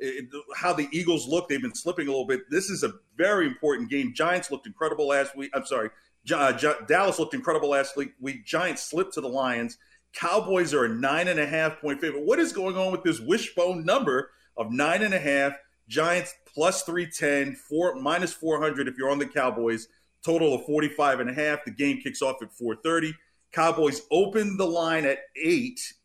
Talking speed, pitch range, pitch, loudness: 200 wpm, 140-180 Hz, 155 Hz, -26 LUFS